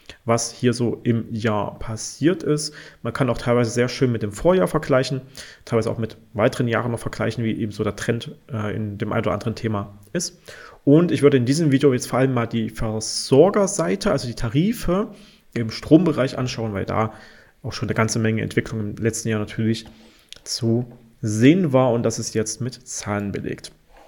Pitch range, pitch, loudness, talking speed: 110-135 Hz, 115 Hz, -22 LUFS, 190 wpm